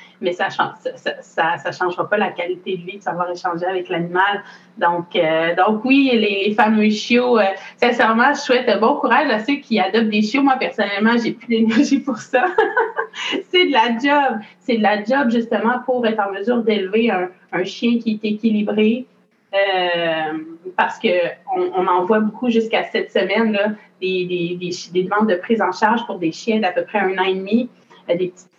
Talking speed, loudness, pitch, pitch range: 205 wpm, -18 LUFS, 215 Hz, 185-245 Hz